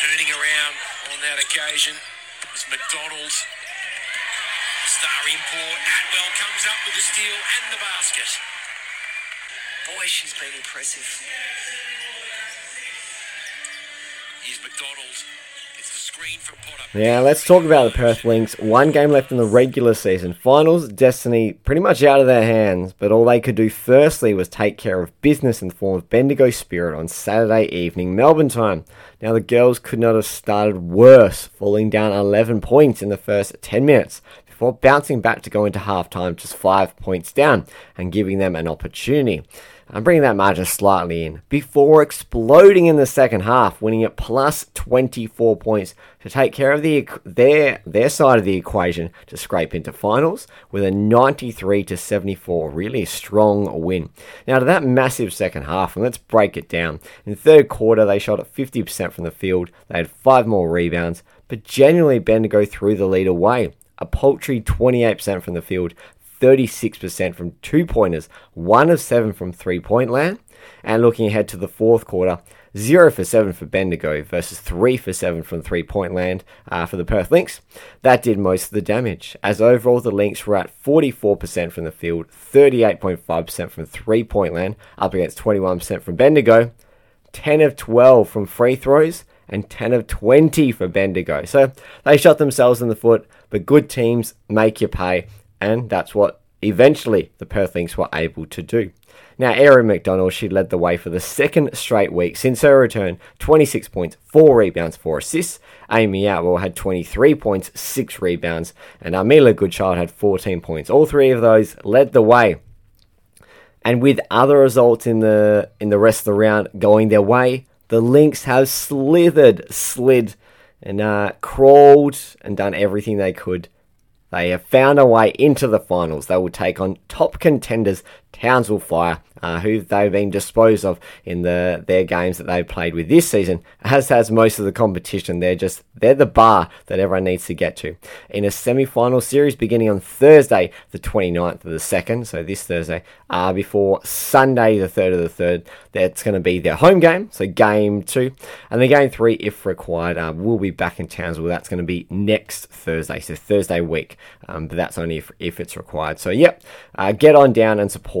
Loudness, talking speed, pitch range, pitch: -16 LUFS, 180 wpm, 90-125 Hz, 105 Hz